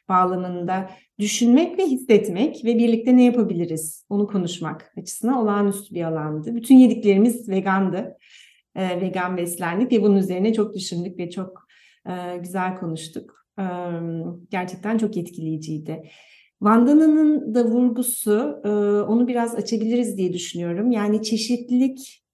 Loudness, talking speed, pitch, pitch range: -21 LUFS, 120 wpm, 205 Hz, 180-235 Hz